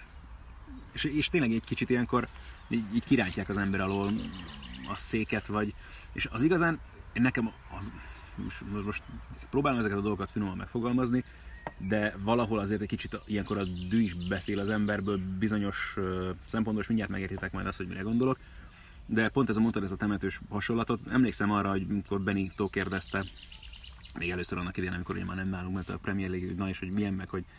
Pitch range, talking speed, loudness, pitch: 95-110 Hz, 180 wpm, -31 LUFS, 100 Hz